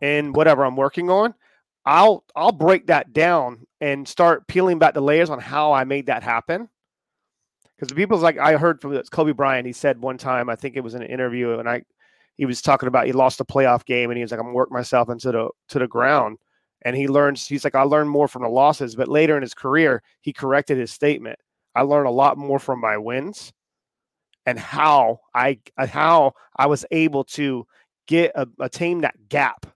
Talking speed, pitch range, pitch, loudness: 220 wpm, 125-150 Hz, 140 Hz, -20 LUFS